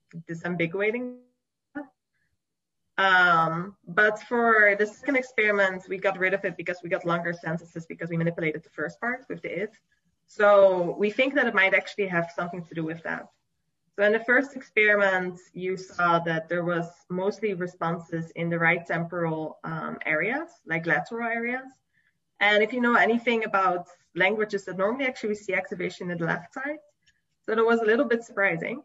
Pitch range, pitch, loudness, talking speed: 175-225 Hz, 195 Hz, -25 LUFS, 175 wpm